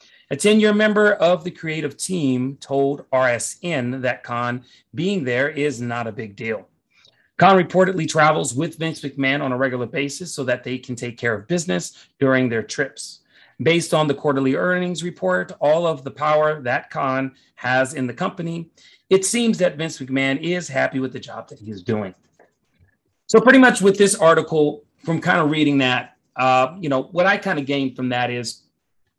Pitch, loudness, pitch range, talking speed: 145 Hz, -20 LUFS, 130-175 Hz, 190 wpm